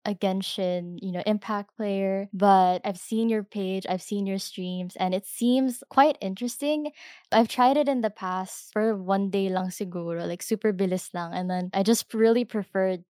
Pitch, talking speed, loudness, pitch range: 195 Hz, 190 wpm, -26 LUFS, 185-225 Hz